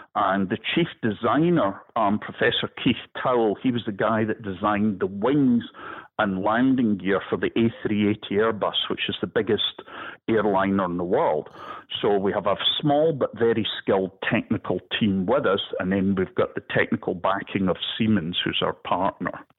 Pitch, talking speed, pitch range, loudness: 105 Hz, 170 wpm, 95-115 Hz, -24 LUFS